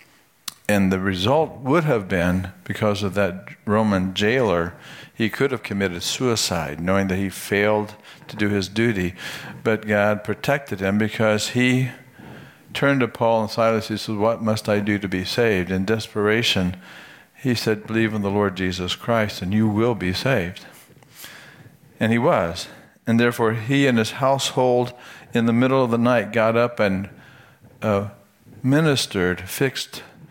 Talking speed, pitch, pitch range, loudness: 160 wpm, 110 Hz, 100-120 Hz, -21 LUFS